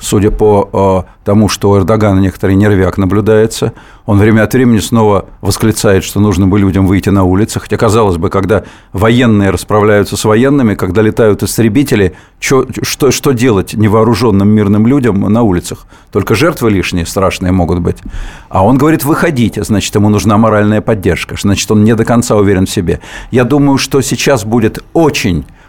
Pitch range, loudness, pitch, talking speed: 95-115 Hz, -10 LUFS, 105 Hz, 165 wpm